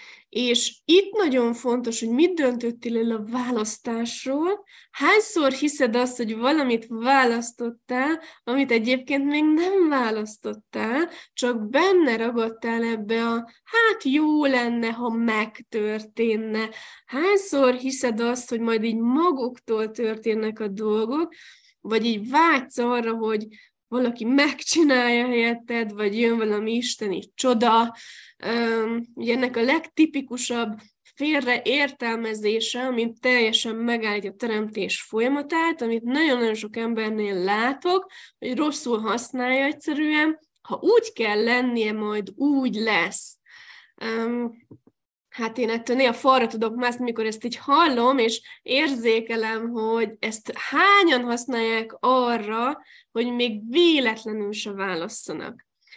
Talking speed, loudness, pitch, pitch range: 115 wpm, -23 LUFS, 240 Hz, 225-275 Hz